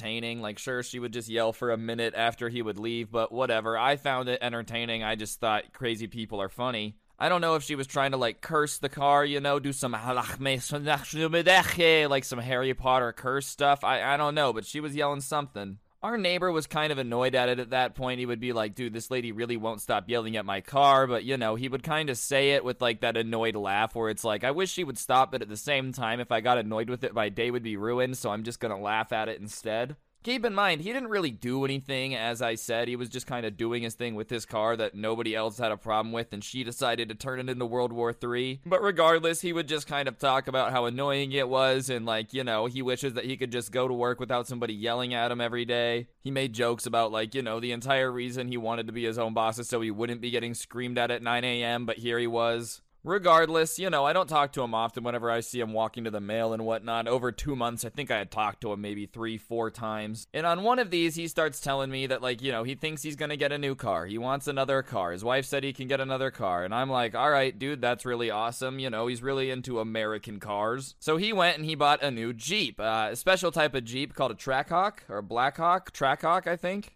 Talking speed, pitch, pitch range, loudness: 265 wpm, 125 Hz, 115-140 Hz, -28 LUFS